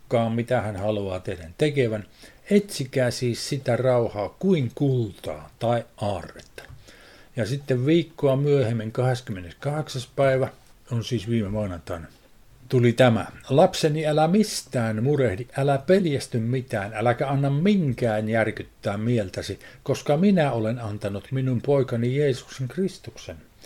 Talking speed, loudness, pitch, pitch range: 115 wpm, -24 LUFS, 125 Hz, 110-140 Hz